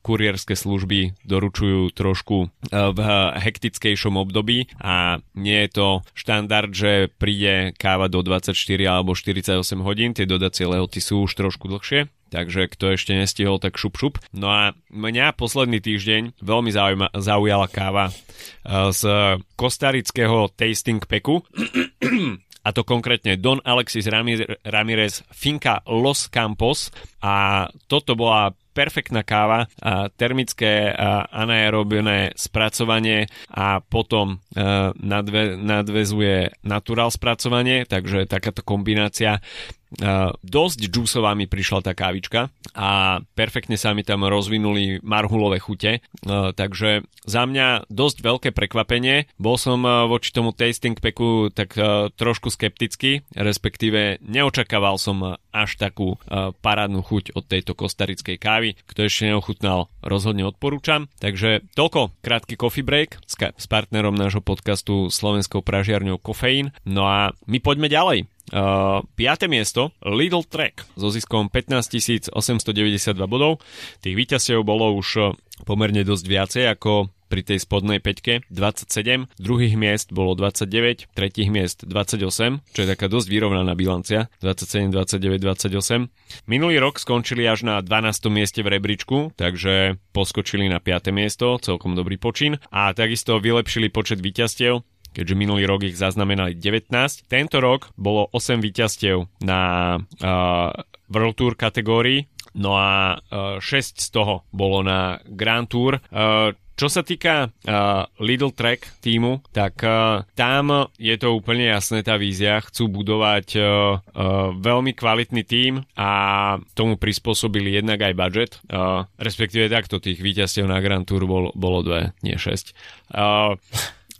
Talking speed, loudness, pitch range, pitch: 130 wpm, -20 LUFS, 95-115 Hz, 105 Hz